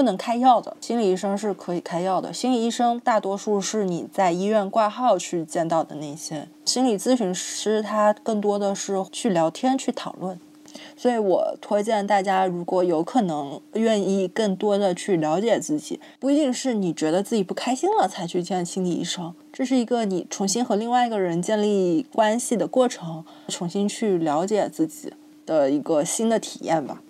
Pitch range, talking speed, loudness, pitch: 185-245 Hz, 285 characters per minute, -23 LUFS, 210 Hz